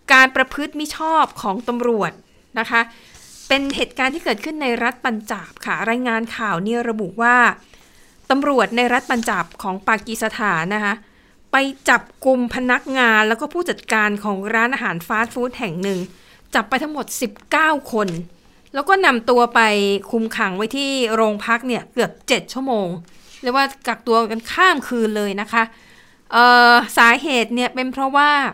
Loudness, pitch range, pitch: -18 LUFS, 220-260 Hz, 235 Hz